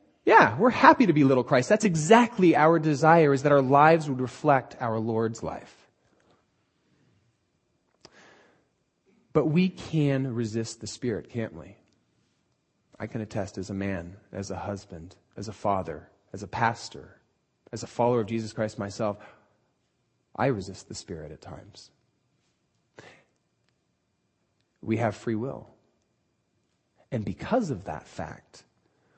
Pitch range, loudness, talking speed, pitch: 100-145 Hz, -24 LUFS, 135 wpm, 115 Hz